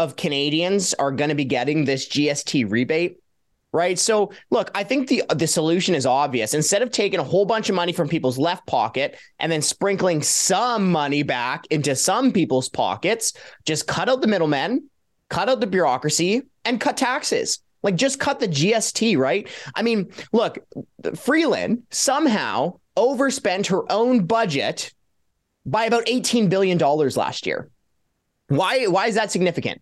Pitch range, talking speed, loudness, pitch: 150-225 Hz, 165 wpm, -21 LUFS, 185 Hz